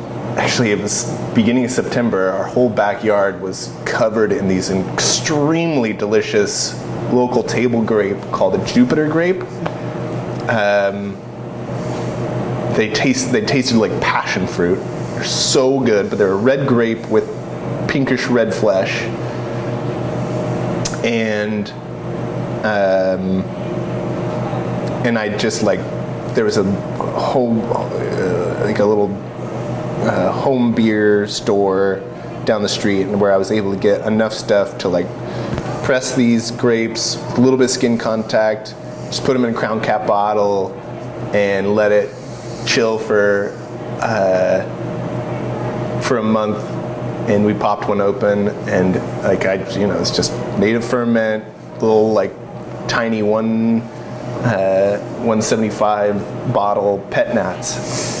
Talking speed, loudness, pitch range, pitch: 130 wpm, -17 LUFS, 100-120 Hz, 110 Hz